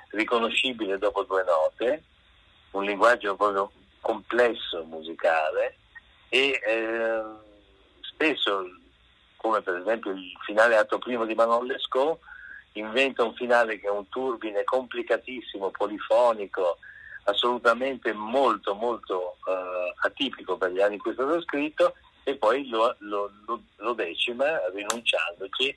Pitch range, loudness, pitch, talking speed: 100-125 Hz, -26 LUFS, 110 Hz, 120 wpm